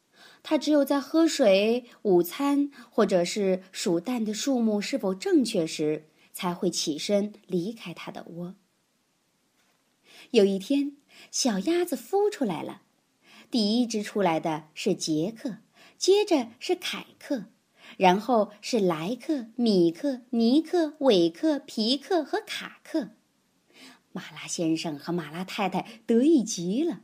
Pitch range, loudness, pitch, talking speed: 185-285 Hz, -26 LUFS, 230 Hz, 185 characters per minute